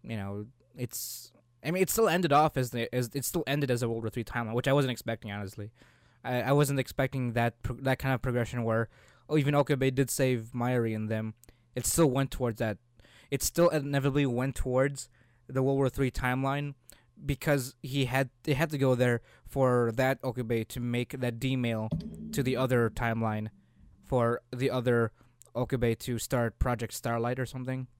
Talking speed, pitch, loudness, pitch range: 190 wpm, 125 Hz, -30 LUFS, 115-135 Hz